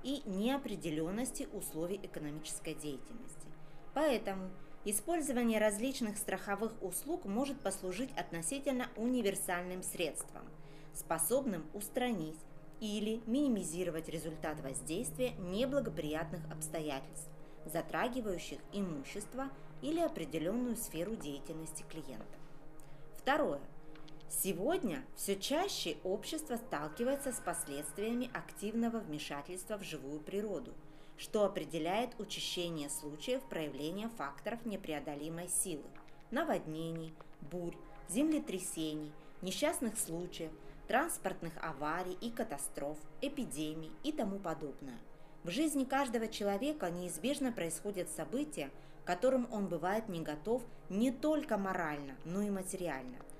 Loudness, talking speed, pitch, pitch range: -39 LUFS, 95 wpm, 185 Hz, 155-230 Hz